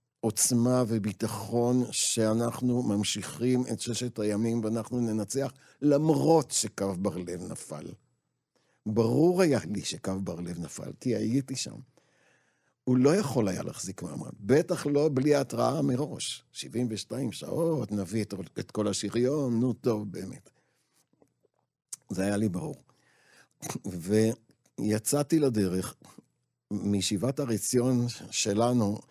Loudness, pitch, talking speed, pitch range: -29 LUFS, 115 Hz, 110 wpm, 105-130 Hz